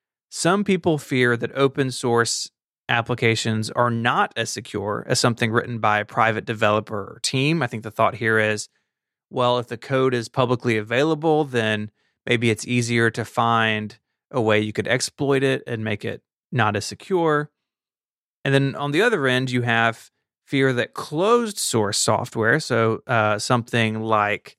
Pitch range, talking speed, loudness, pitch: 110-130 Hz, 165 wpm, -21 LUFS, 120 Hz